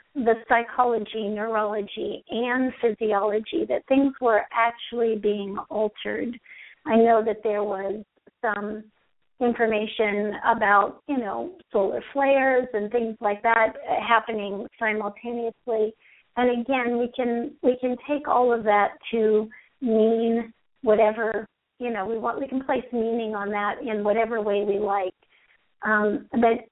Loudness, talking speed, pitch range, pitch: -24 LUFS, 135 wpm, 210-240 Hz, 225 Hz